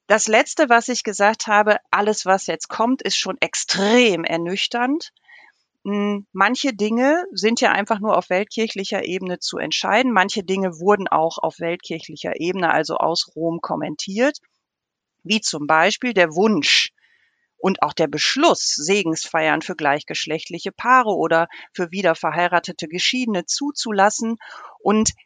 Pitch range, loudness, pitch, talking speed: 170-225 Hz, -19 LUFS, 200 Hz, 135 wpm